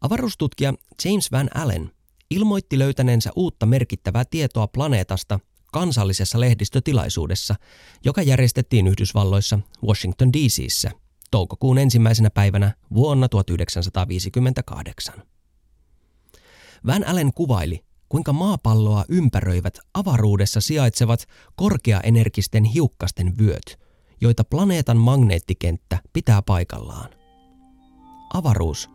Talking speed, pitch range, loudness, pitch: 80 wpm, 95-135 Hz, -20 LUFS, 115 Hz